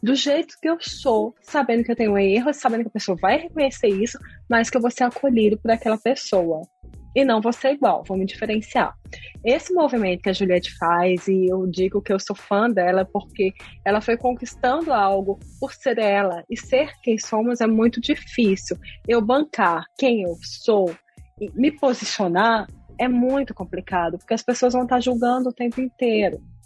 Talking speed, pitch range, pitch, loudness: 190 wpm, 195-250 Hz, 230 Hz, -21 LUFS